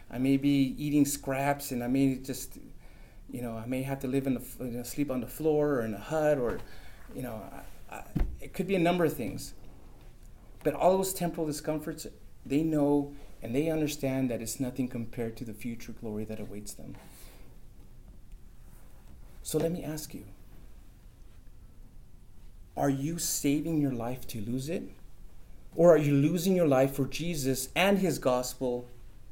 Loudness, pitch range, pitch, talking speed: -30 LUFS, 120-150 Hz, 135 Hz, 170 wpm